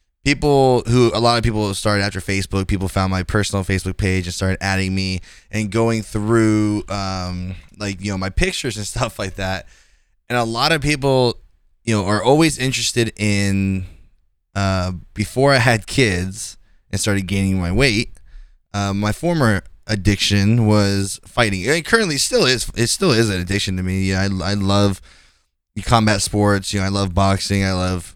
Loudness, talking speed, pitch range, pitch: -18 LUFS, 180 wpm, 95-115 Hz, 100 Hz